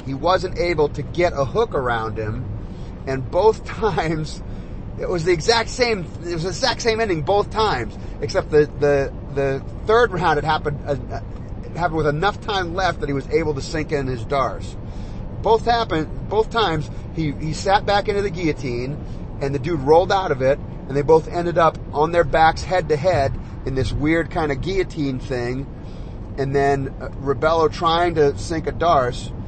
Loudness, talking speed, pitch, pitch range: -20 LUFS, 195 wpm, 145 Hz, 125-175 Hz